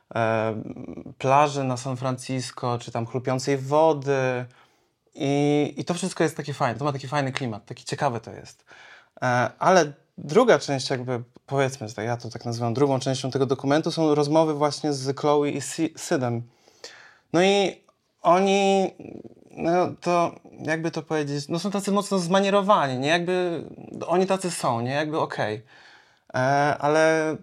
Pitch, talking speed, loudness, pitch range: 145 Hz, 145 wpm, -24 LUFS, 130-165 Hz